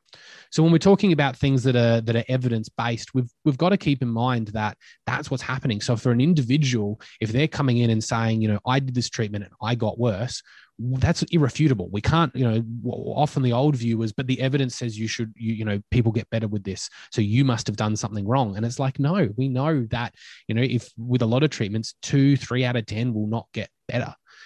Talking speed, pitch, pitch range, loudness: 245 wpm, 120 Hz, 115-135 Hz, -23 LUFS